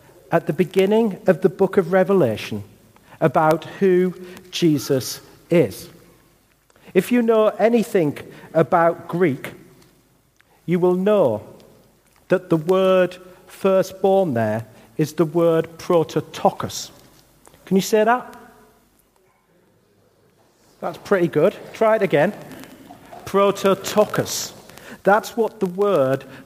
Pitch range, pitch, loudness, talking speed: 165-195 Hz, 185 Hz, -19 LUFS, 100 wpm